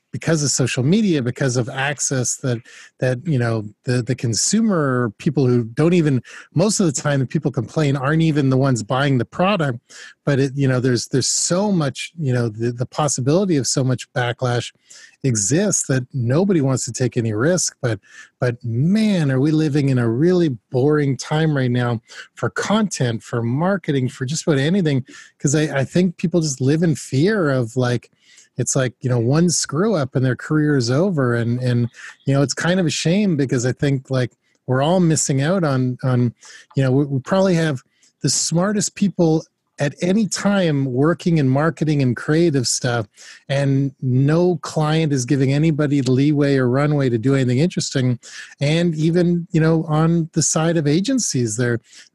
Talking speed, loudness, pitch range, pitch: 190 wpm, -19 LUFS, 125-165 Hz, 140 Hz